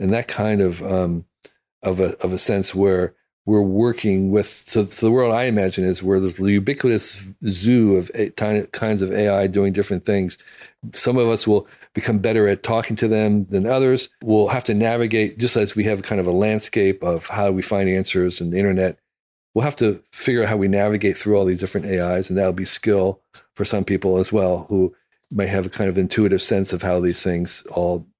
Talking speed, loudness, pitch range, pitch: 215 wpm, -19 LUFS, 95-110 Hz, 100 Hz